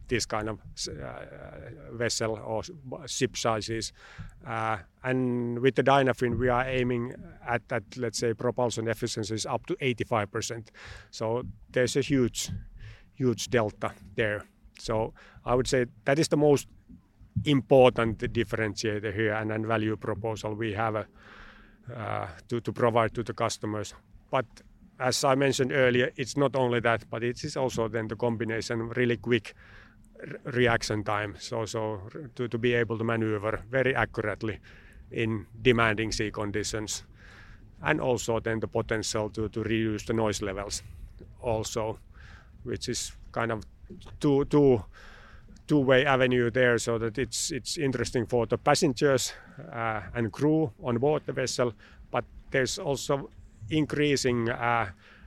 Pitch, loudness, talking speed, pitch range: 115 Hz, -28 LUFS, 145 wpm, 110-125 Hz